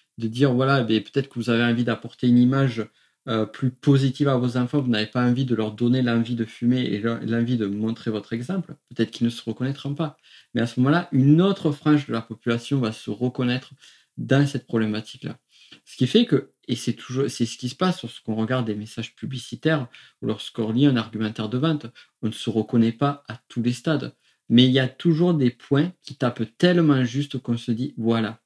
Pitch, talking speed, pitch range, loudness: 125 Hz, 220 wpm, 115-135 Hz, -23 LUFS